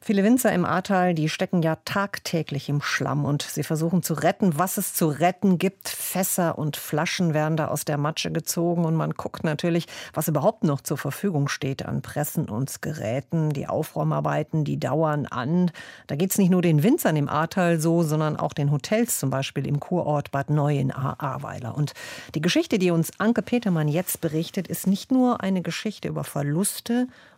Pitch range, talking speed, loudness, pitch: 150-185 Hz, 185 wpm, -24 LUFS, 165 Hz